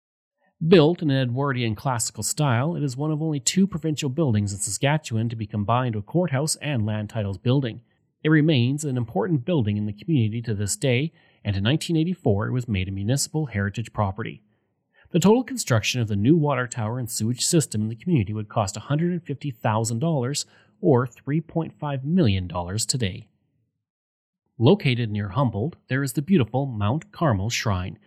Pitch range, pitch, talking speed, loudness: 110-155 Hz, 130 Hz, 165 wpm, -24 LUFS